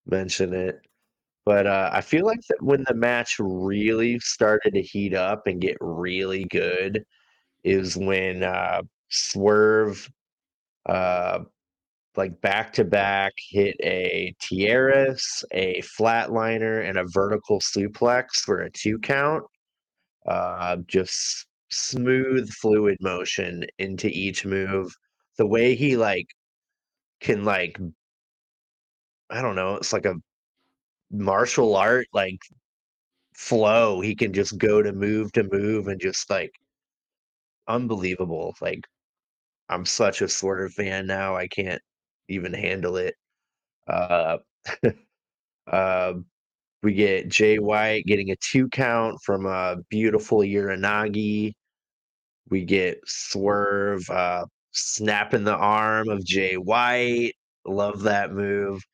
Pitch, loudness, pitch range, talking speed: 100 Hz, -24 LUFS, 95-110 Hz, 120 wpm